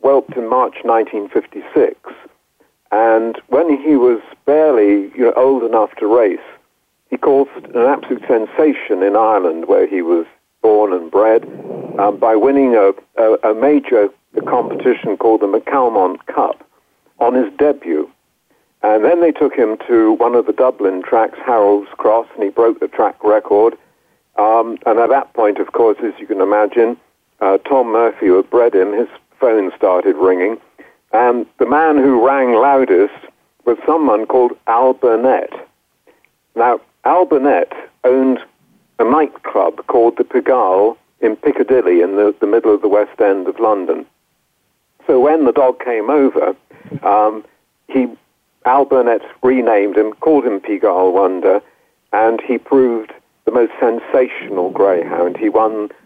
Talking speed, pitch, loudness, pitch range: 150 wpm, 120 Hz, -14 LUFS, 105-145 Hz